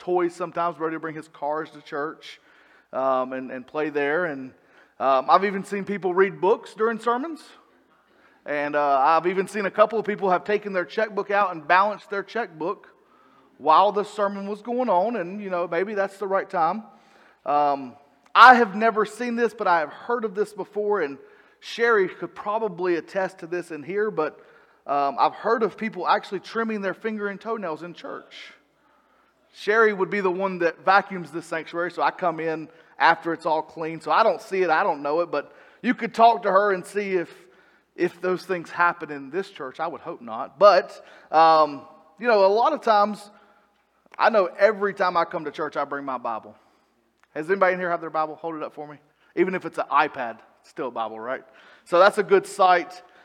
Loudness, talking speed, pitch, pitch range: -23 LUFS, 205 wpm, 185 Hz, 160-210 Hz